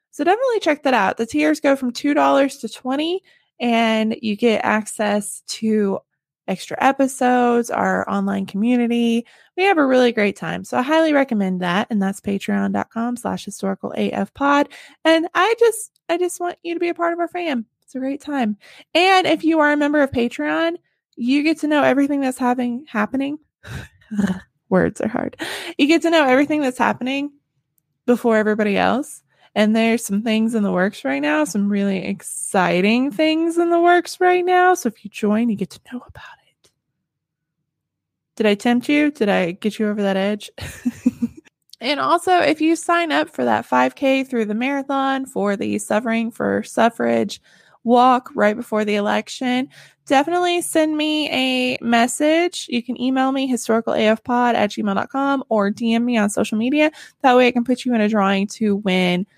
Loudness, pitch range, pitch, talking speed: -19 LUFS, 210-295 Hz, 245 Hz, 180 wpm